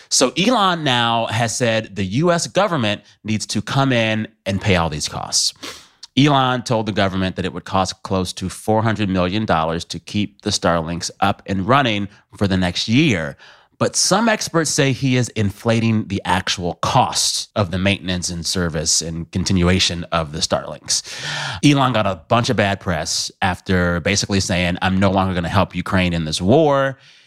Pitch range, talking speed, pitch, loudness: 90-120 Hz, 175 wpm, 100 Hz, -18 LUFS